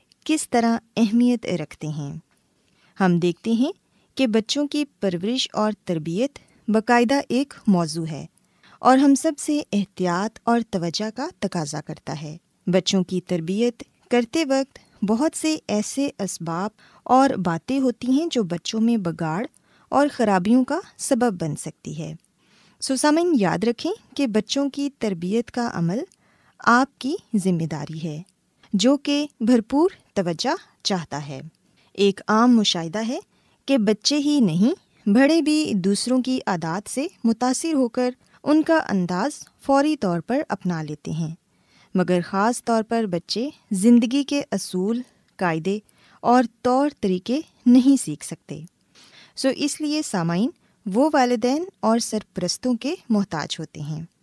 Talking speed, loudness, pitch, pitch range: 140 wpm, -22 LUFS, 225 Hz, 180-270 Hz